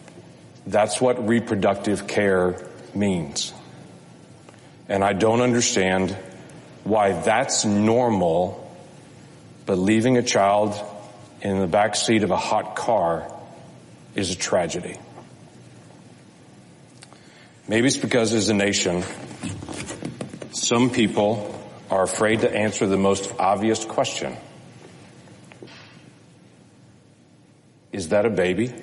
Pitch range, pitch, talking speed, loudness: 95-110 Hz, 105 Hz, 100 wpm, -22 LUFS